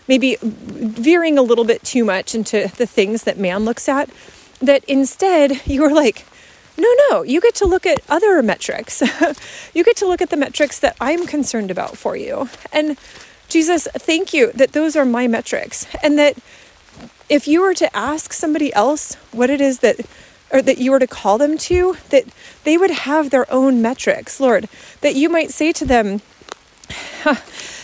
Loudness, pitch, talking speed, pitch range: -16 LUFS, 285 Hz, 185 wpm, 245-320 Hz